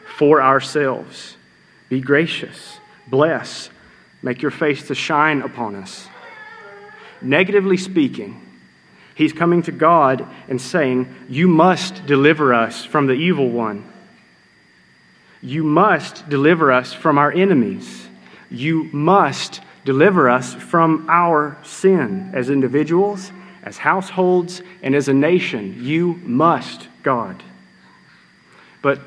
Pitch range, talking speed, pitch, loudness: 130-180 Hz, 110 wpm, 150 Hz, -17 LUFS